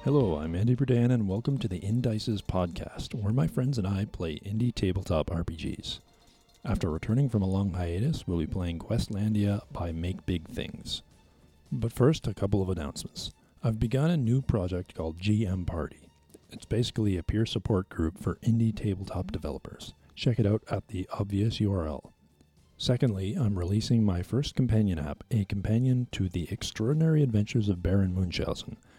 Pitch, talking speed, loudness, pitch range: 105 Hz, 165 wpm, -29 LUFS, 90-115 Hz